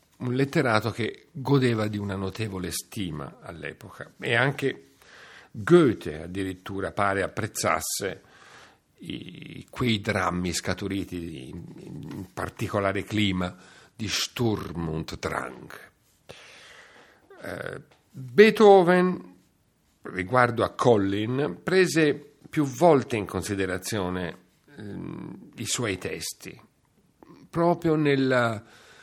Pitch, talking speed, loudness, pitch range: 110 Hz, 90 wpm, -25 LUFS, 95-135 Hz